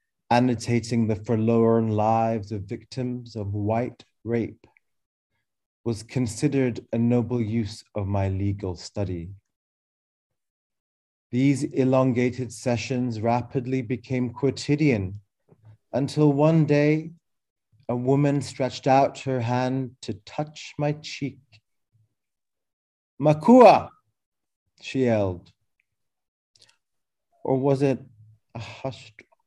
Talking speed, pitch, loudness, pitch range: 90 wpm, 120 Hz, -24 LUFS, 110-135 Hz